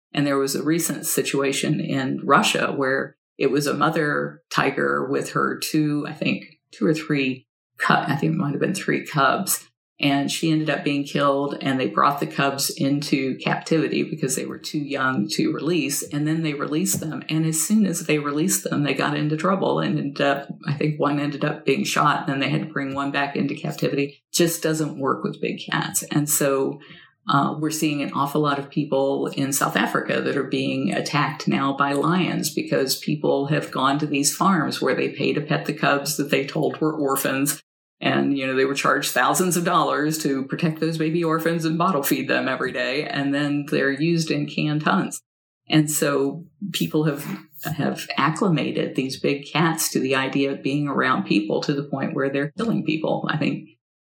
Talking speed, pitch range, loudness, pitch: 205 wpm, 140-160 Hz, -22 LUFS, 145 Hz